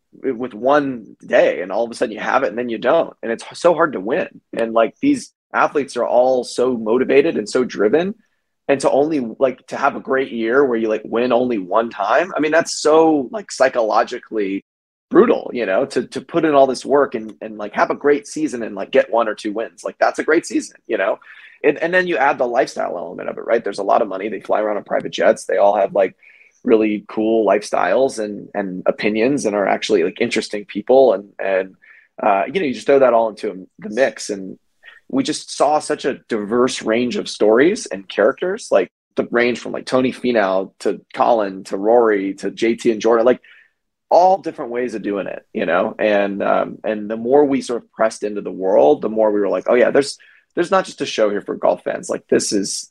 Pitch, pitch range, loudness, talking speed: 120 Hz, 110-155 Hz, -18 LUFS, 230 wpm